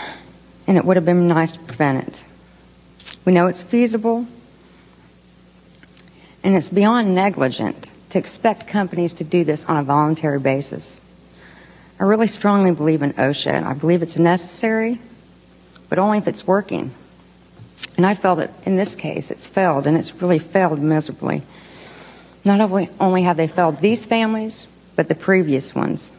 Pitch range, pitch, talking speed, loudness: 155-200 Hz, 180 Hz, 155 wpm, -18 LUFS